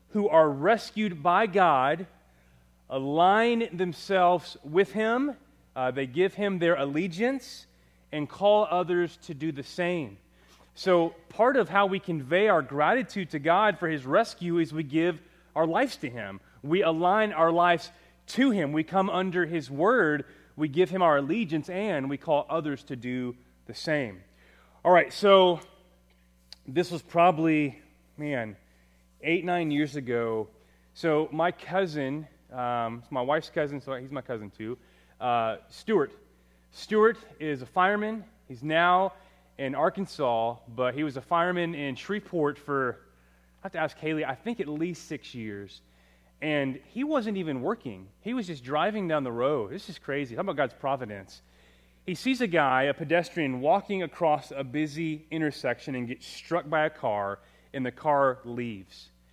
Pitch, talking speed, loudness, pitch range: 155 Hz, 160 wpm, -27 LUFS, 125-180 Hz